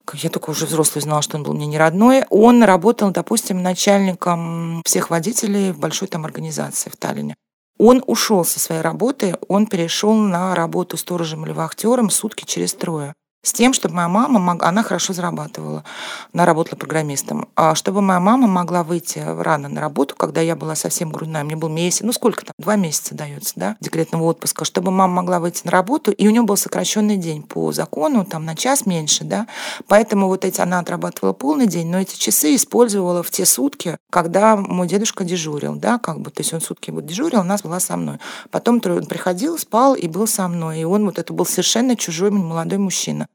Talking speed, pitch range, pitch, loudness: 200 wpm, 160-210 Hz, 180 Hz, -18 LUFS